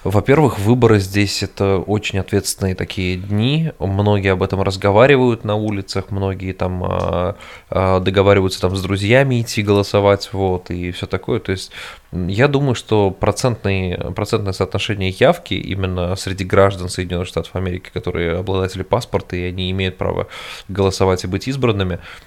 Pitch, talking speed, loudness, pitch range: 95 Hz, 135 wpm, -18 LUFS, 95-105 Hz